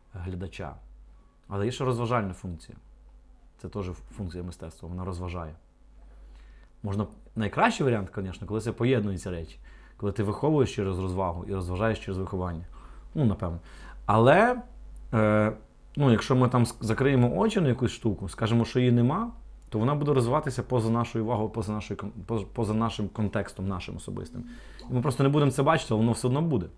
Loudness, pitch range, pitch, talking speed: -27 LUFS, 95-125 Hz, 110 Hz, 160 wpm